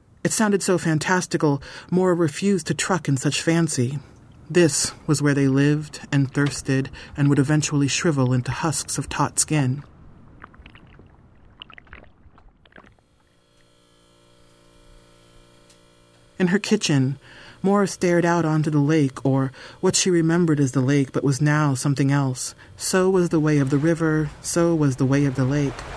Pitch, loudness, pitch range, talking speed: 145 Hz, -21 LUFS, 135-170 Hz, 145 wpm